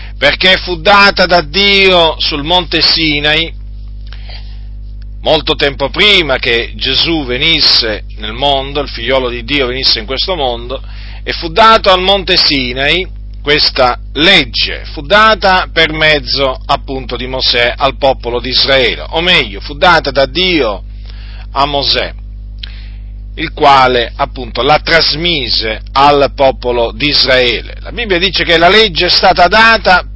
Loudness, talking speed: -9 LUFS, 135 wpm